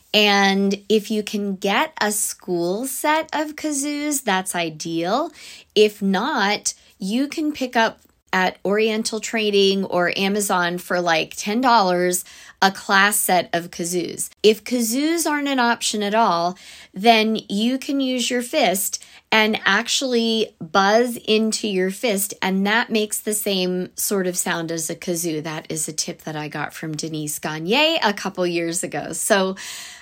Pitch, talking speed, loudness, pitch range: 205 Hz, 150 wpm, -20 LUFS, 180-235 Hz